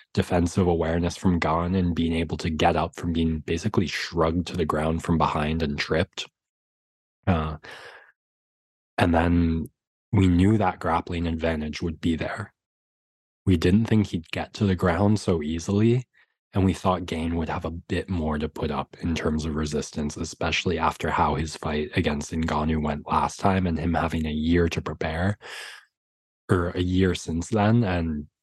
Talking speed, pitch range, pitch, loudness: 170 wpm, 80-90 Hz, 85 Hz, -25 LUFS